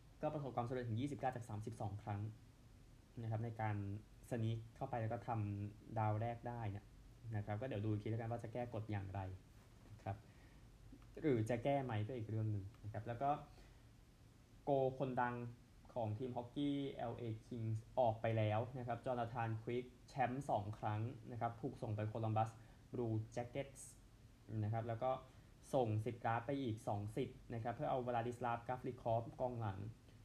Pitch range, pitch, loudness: 110-125 Hz, 115 Hz, -44 LUFS